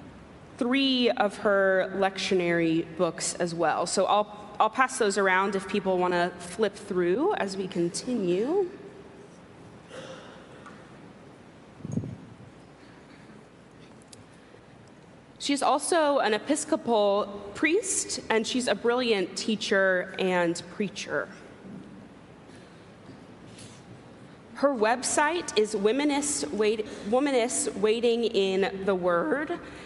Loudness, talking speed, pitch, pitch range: -26 LUFS, 90 wpm, 210 Hz, 190-255 Hz